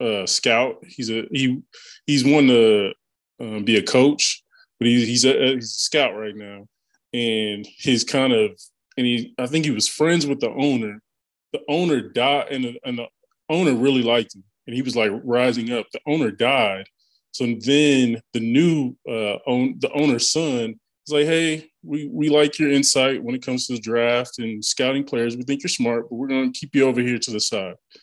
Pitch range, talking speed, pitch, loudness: 115-145 Hz, 205 wpm, 125 Hz, -20 LUFS